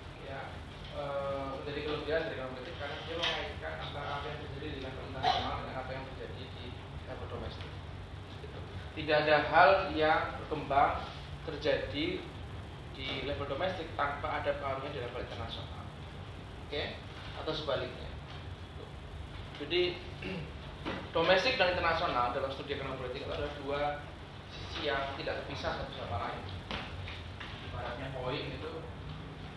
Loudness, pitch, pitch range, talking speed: -35 LUFS, 130 Hz, 95-145 Hz, 130 wpm